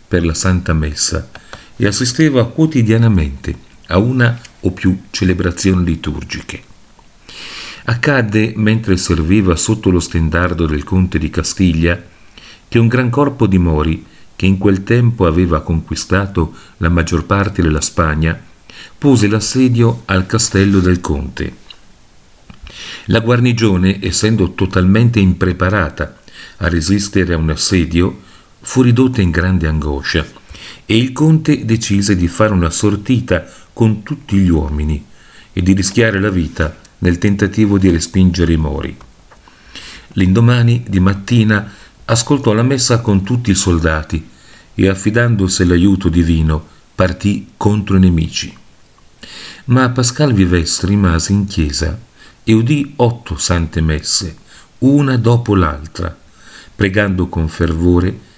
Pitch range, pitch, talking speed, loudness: 85-110 Hz, 95 Hz, 120 wpm, -14 LUFS